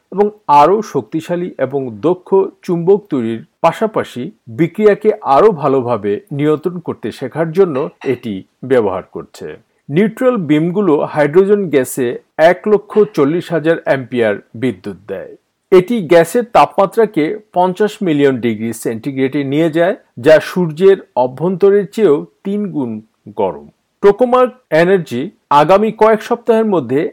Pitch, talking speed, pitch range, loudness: 170 Hz, 115 wpm, 140-205 Hz, -14 LUFS